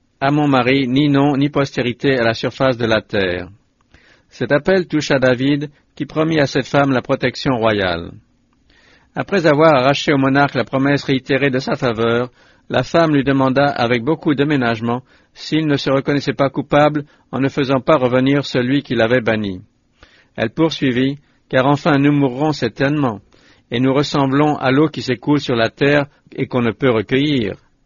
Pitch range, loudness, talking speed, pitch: 125-145 Hz, -16 LUFS, 175 wpm, 135 Hz